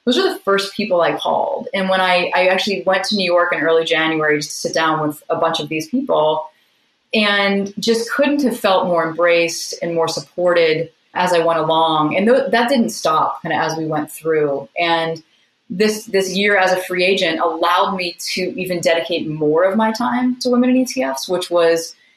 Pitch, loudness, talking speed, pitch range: 180 Hz, -17 LUFS, 210 wpm, 165-205 Hz